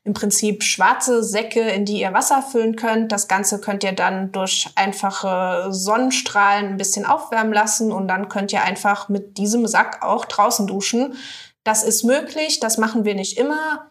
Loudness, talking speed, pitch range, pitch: -19 LUFS, 175 wpm, 200-235 Hz, 210 Hz